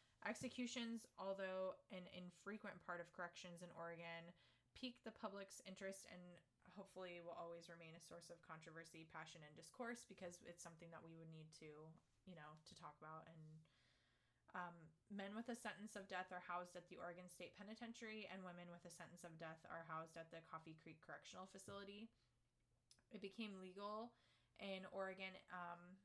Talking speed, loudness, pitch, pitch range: 170 wpm, -56 LUFS, 175 Hz, 165-195 Hz